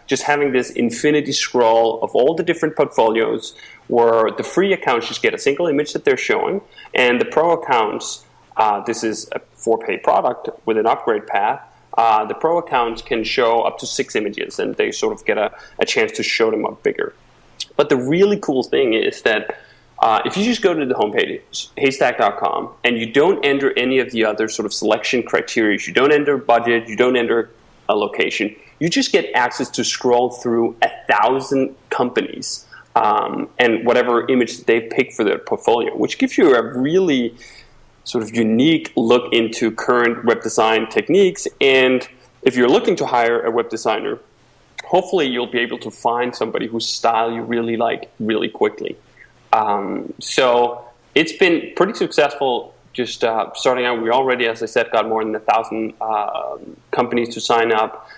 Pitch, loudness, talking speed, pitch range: 125 Hz, -18 LUFS, 185 wpm, 115-170 Hz